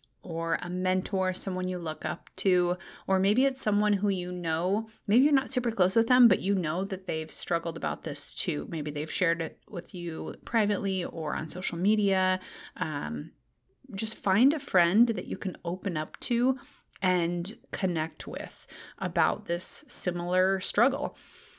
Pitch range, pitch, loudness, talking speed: 175-215 Hz, 185 Hz, -27 LUFS, 165 wpm